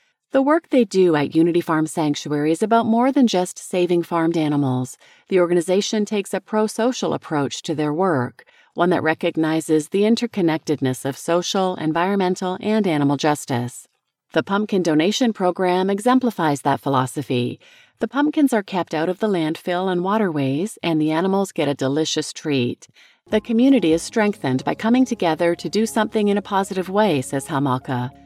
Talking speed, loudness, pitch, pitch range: 160 wpm, -20 LUFS, 175 Hz, 155-210 Hz